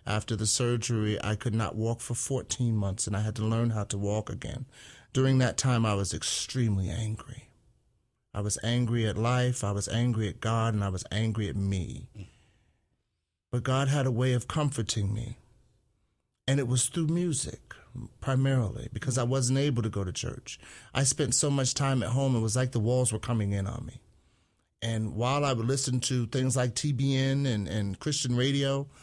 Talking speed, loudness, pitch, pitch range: 195 wpm, -29 LUFS, 120 Hz, 110-130 Hz